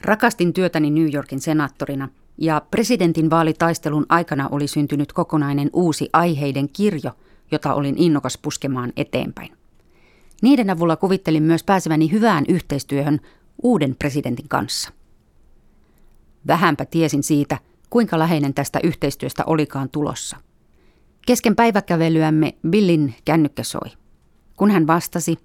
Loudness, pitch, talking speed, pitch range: -19 LUFS, 155 Hz, 110 wpm, 145-175 Hz